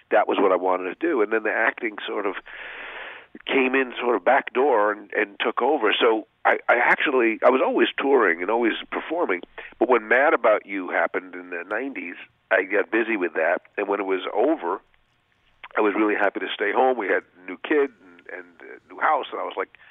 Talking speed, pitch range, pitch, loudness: 225 wpm, 90-135 Hz, 105 Hz, -22 LUFS